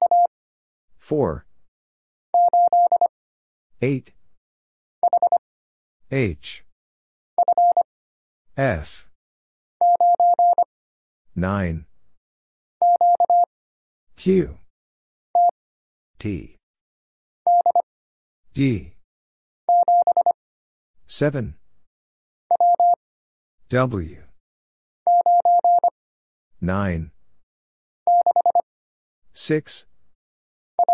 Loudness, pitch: -20 LUFS, 140 Hz